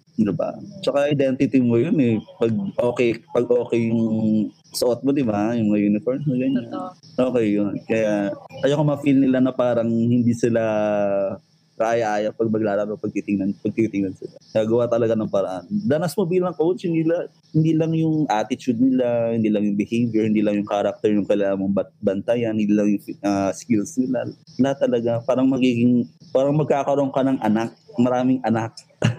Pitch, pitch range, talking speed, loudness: 115 Hz, 105-130 Hz, 165 wpm, -21 LUFS